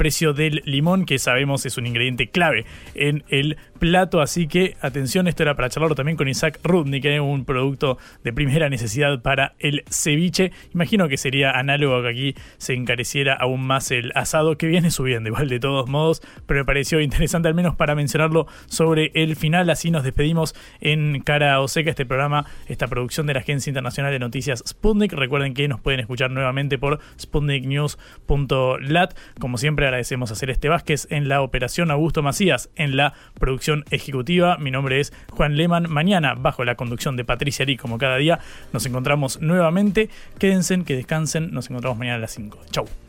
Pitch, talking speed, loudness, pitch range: 145 Hz, 185 wpm, -21 LUFS, 130-160 Hz